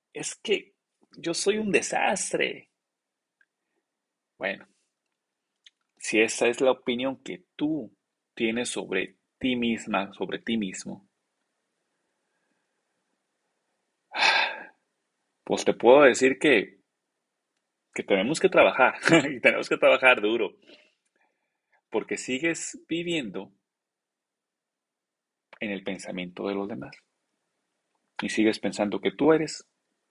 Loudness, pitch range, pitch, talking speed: -25 LUFS, 100-160 Hz, 120 Hz, 100 wpm